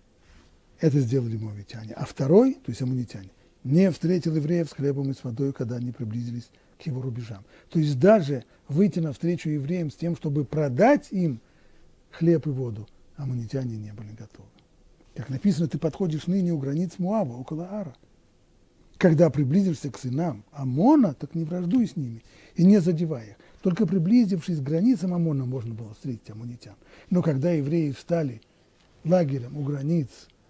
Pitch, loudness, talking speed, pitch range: 150 Hz, -25 LUFS, 155 wpm, 125-175 Hz